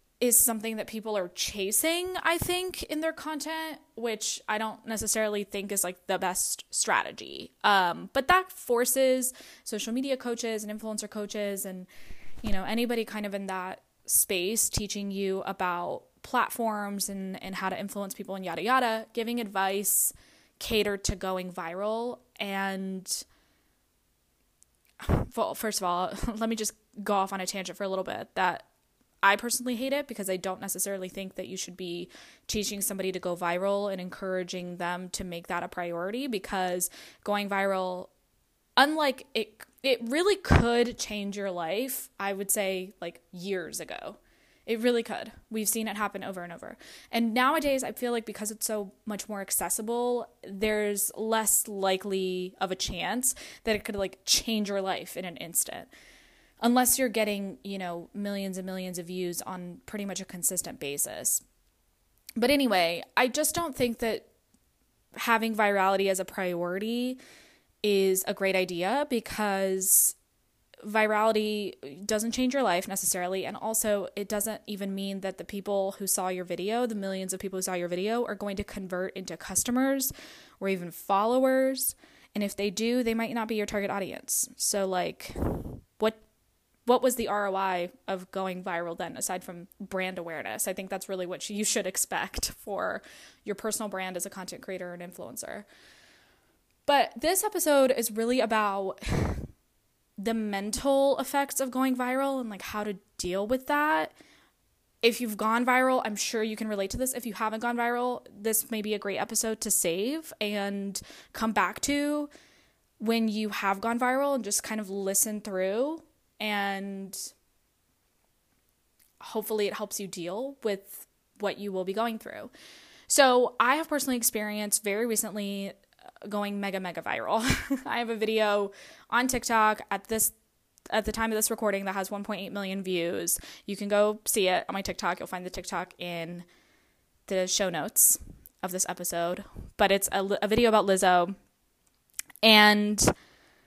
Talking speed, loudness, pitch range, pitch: 165 wpm, -28 LUFS, 190-230 Hz, 205 Hz